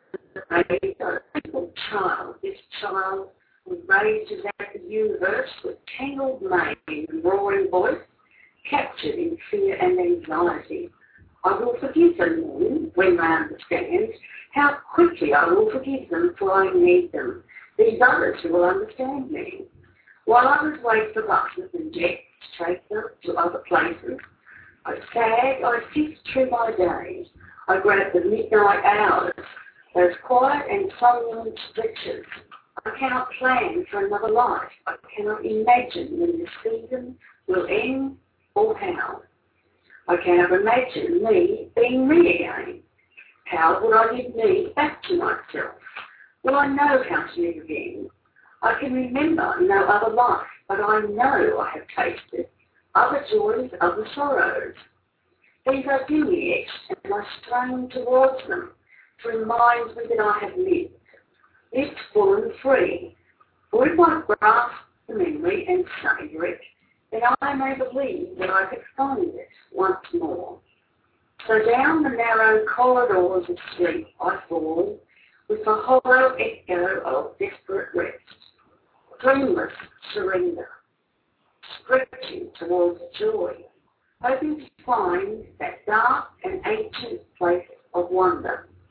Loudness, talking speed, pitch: -22 LUFS, 135 wpm, 275 Hz